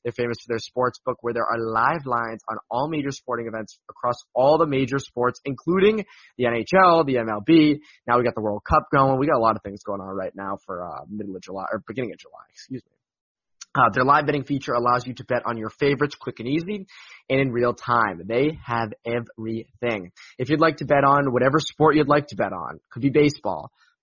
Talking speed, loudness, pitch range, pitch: 230 wpm, -22 LUFS, 115-145 Hz, 125 Hz